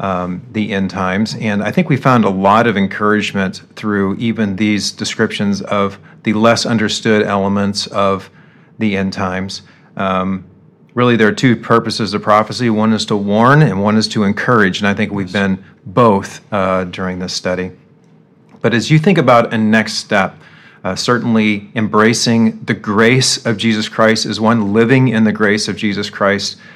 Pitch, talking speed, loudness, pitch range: 105 Hz, 175 wpm, -14 LUFS, 100-115 Hz